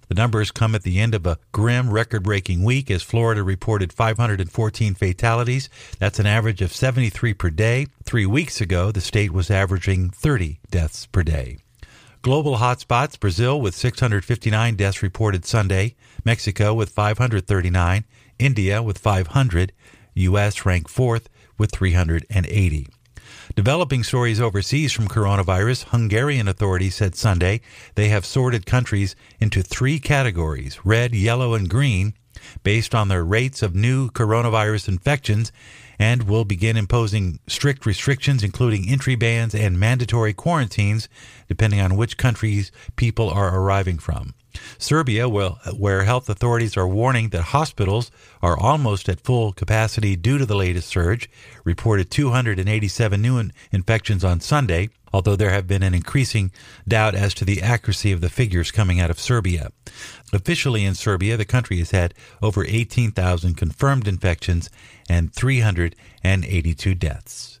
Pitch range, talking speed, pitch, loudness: 95-120 Hz, 140 wpm, 110 Hz, -20 LUFS